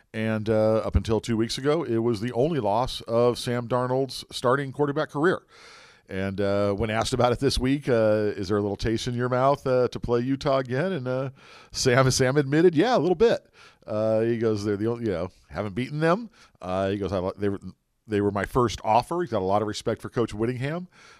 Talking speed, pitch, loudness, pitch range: 220 wpm, 120 Hz, -25 LUFS, 105-135 Hz